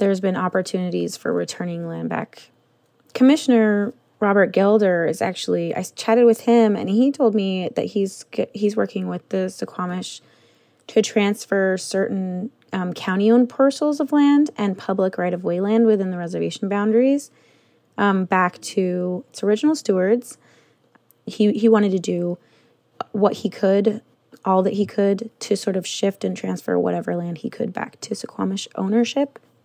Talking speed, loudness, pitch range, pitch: 160 wpm, -21 LUFS, 185-225 Hz, 200 Hz